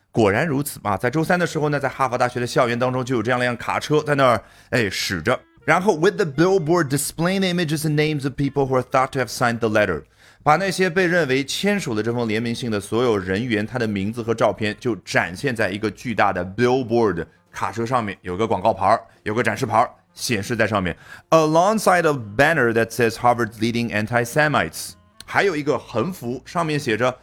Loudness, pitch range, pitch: -21 LUFS, 115-150 Hz, 125 Hz